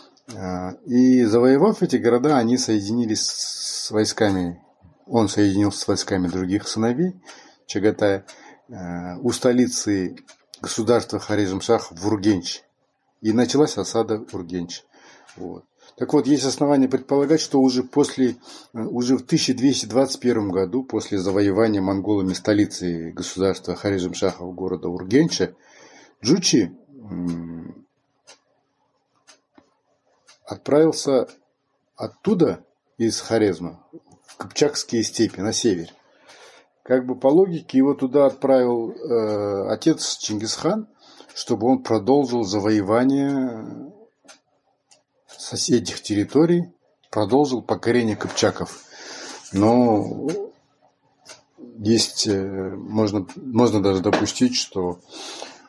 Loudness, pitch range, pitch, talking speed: -21 LUFS, 100-130 Hz, 110 Hz, 90 wpm